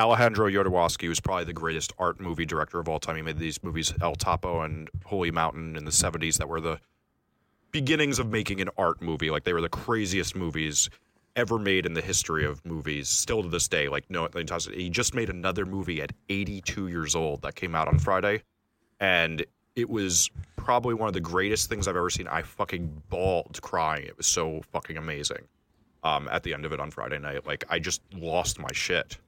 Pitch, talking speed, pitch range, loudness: 85 Hz, 210 wpm, 80-100 Hz, -28 LUFS